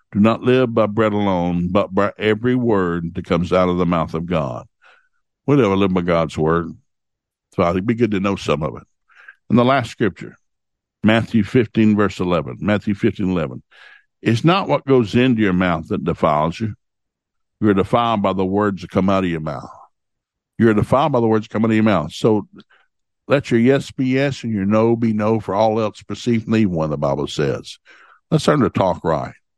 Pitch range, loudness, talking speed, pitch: 90-115 Hz, -18 LUFS, 210 wpm, 105 Hz